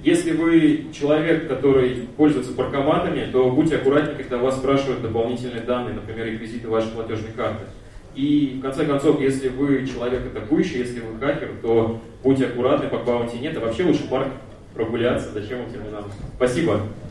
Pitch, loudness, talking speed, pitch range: 130 Hz, -22 LUFS, 160 wpm, 115-140 Hz